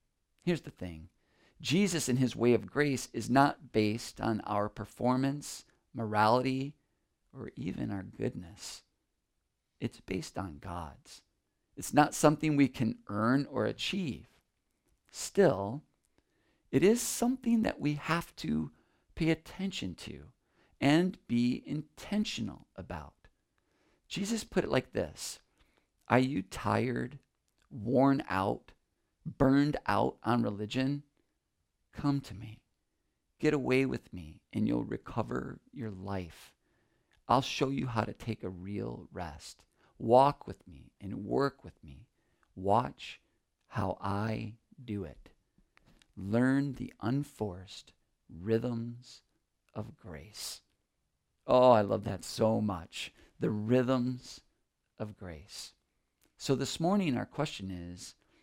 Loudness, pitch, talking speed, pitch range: -32 LUFS, 120 Hz, 120 wpm, 105-140 Hz